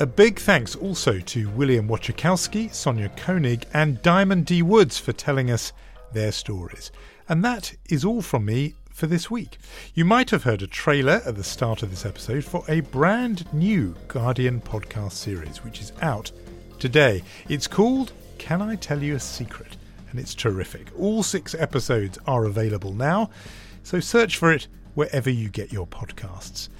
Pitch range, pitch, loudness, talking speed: 105-170 Hz, 135 Hz, -23 LUFS, 170 wpm